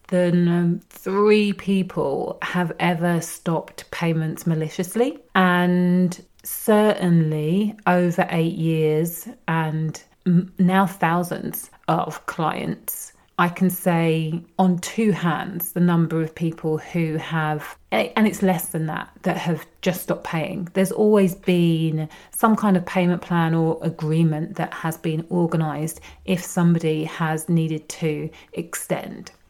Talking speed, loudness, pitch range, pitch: 120 wpm, -22 LUFS, 160-185 Hz, 175 Hz